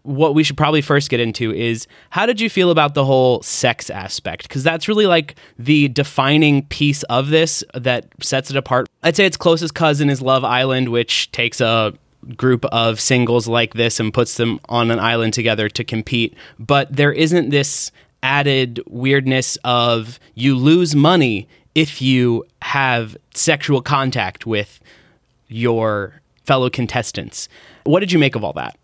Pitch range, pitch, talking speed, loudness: 120-145 Hz, 130 Hz, 170 wpm, -17 LUFS